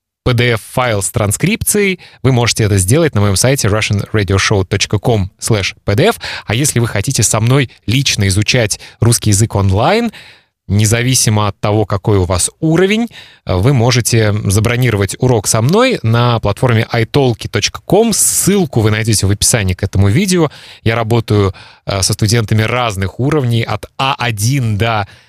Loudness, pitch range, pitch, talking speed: -13 LUFS, 105-125 Hz, 115 Hz, 135 wpm